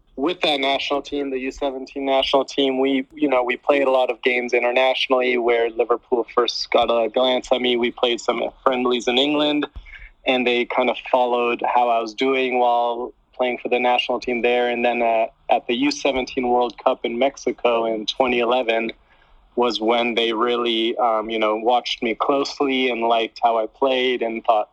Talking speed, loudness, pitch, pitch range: 185 wpm, -20 LUFS, 125 Hz, 120-130 Hz